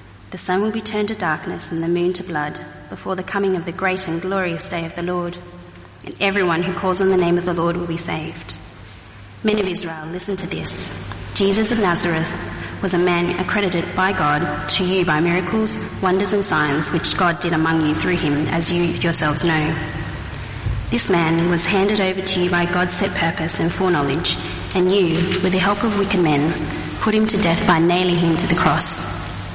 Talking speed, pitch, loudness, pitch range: 205 wpm, 175 Hz, -19 LUFS, 155-185 Hz